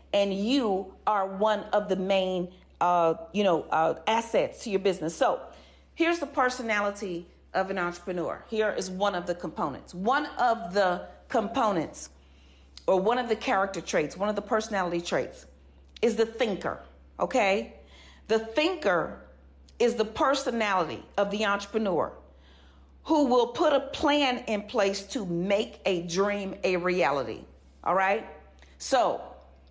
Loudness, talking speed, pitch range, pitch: -28 LUFS, 145 wpm, 170-220 Hz, 195 Hz